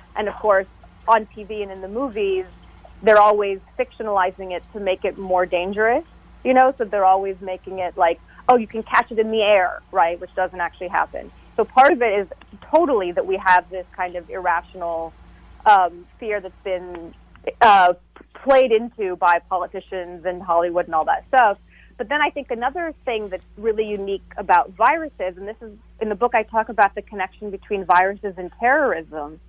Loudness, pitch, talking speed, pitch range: -20 LUFS, 200 Hz, 190 wpm, 180-225 Hz